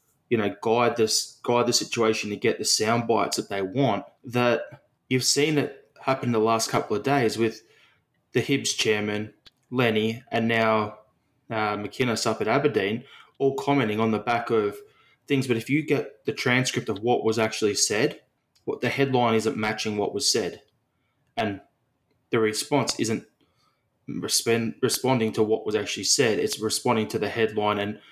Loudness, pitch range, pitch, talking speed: -25 LUFS, 110-130 Hz, 115 Hz, 170 wpm